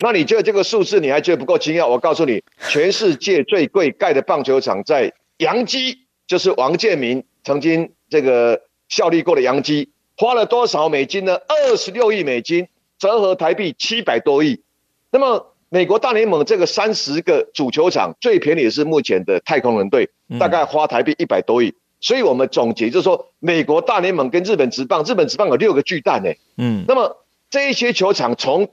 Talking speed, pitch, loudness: 300 characters per minute, 240 Hz, -17 LUFS